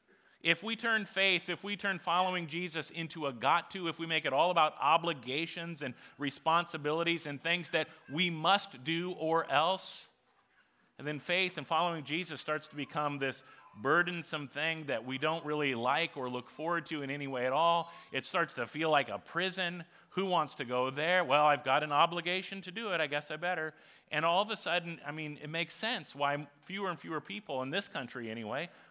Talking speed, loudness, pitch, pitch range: 205 wpm, -33 LUFS, 160 Hz, 145-175 Hz